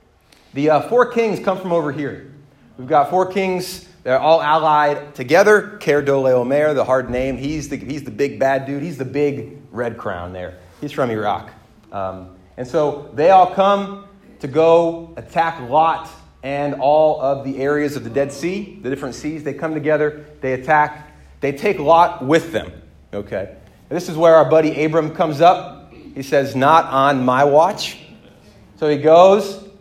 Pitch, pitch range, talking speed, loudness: 150 Hz, 135-165 Hz, 175 wpm, -17 LUFS